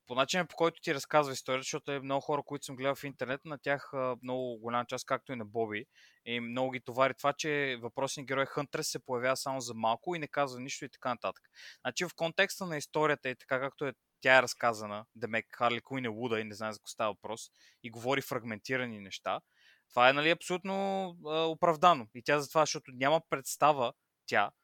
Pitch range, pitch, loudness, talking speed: 125-150 Hz, 135 Hz, -33 LUFS, 220 wpm